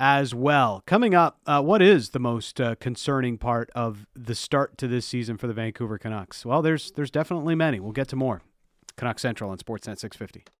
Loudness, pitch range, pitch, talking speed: -25 LUFS, 115-140 Hz, 120 Hz, 205 wpm